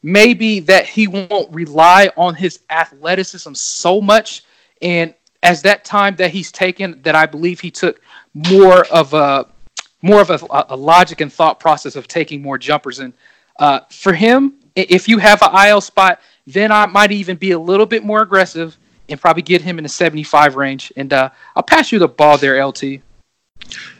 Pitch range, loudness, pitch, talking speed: 155-200 Hz, -12 LUFS, 175 Hz, 185 wpm